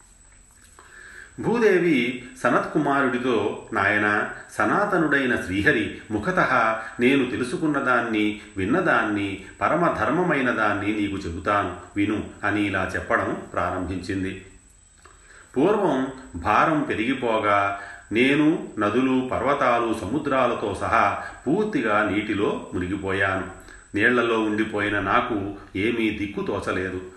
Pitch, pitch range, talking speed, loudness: 105 Hz, 95-115 Hz, 75 wpm, -23 LUFS